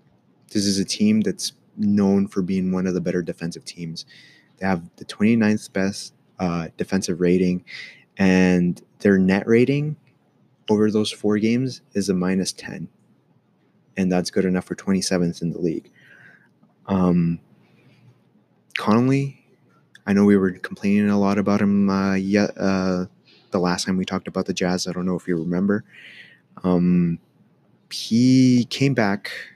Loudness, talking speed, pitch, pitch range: -21 LUFS, 150 wpm, 95 Hz, 90-105 Hz